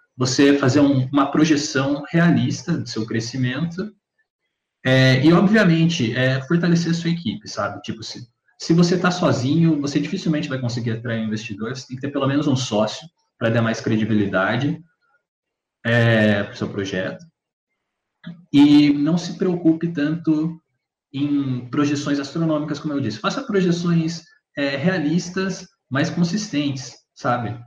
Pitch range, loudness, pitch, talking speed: 125-170 Hz, -20 LUFS, 145 Hz, 140 wpm